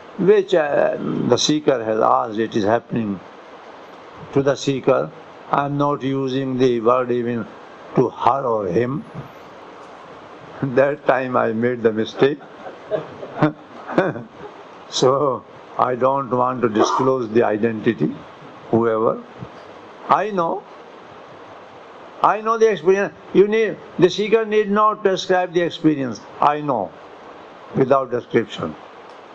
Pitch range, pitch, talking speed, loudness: 120-165 Hz, 135 Hz, 115 wpm, -19 LUFS